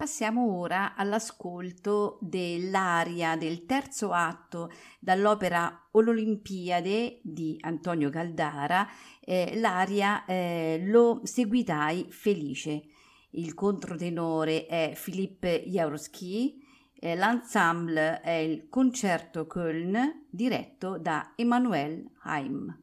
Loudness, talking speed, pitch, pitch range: -29 LUFS, 85 wpm, 185 Hz, 165-220 Hz